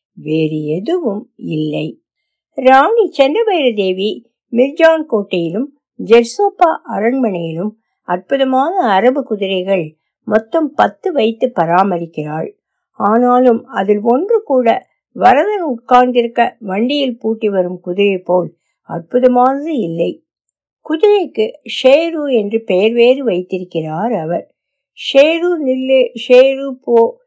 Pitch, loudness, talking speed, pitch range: 240 Hz, -14 LUFS, 90 wpm, 195-275 Hz